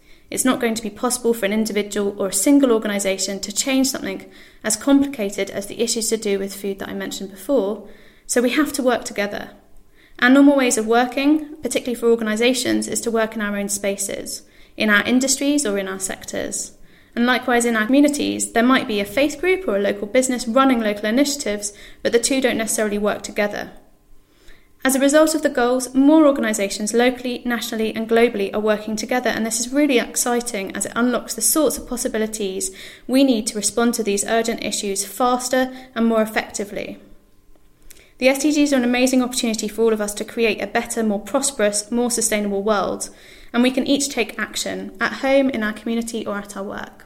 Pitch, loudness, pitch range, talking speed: 230 Hz, -19 LUFS, 210-255 Hz, 200 wpm